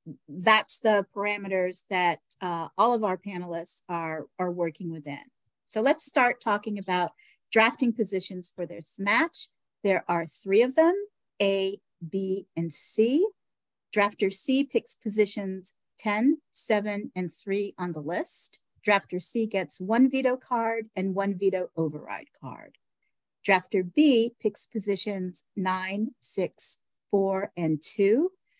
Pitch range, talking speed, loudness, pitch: 180-225 Hz, 130 wpm, -26 LUFS, 200 Hz